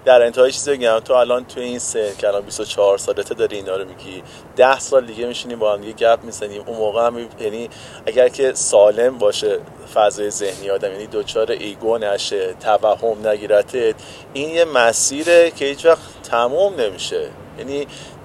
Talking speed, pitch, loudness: 180 wpm, 145 Hz, -18 LUFS